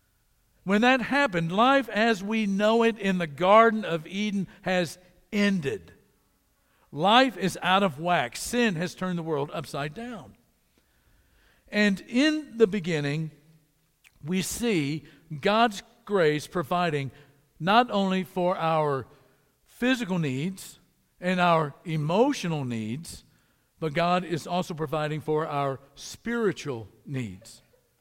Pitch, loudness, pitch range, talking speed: 175 Hz, -26 LUFS, 150-210 Hz, 120 wpm